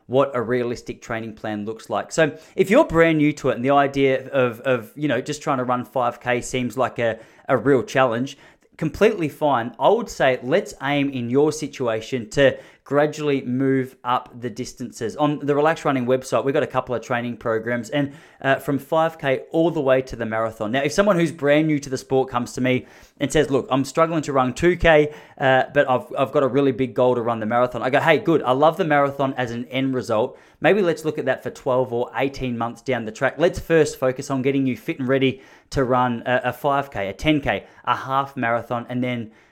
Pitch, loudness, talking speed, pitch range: 130 Hz, -21 LUFS, 225 wpm, 125-145 Hz